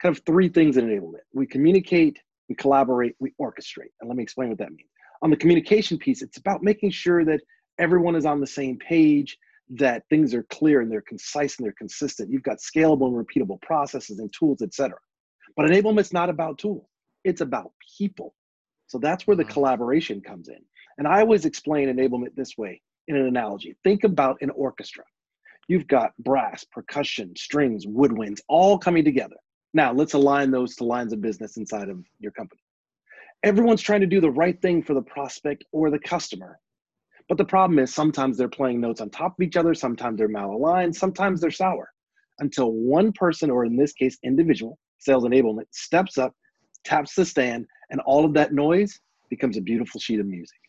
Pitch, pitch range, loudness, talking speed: 150 Hz, 130-180 Hz, -23 LUFS, 190 wpm